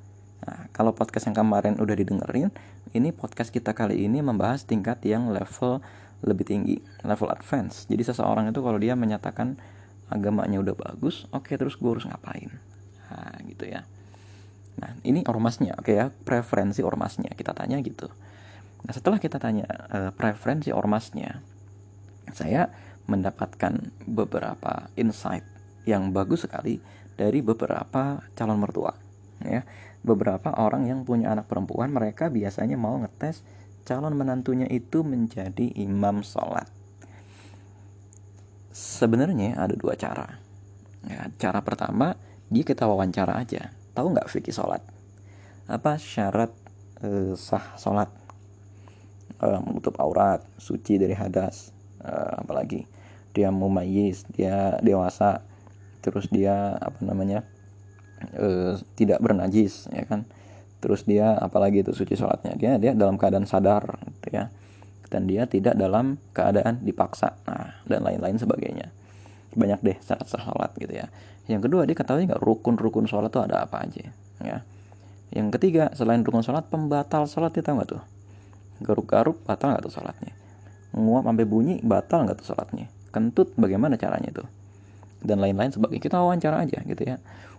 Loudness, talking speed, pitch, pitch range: -26 LUFS, 140 wpm, 100 Hz, 100-115 Hz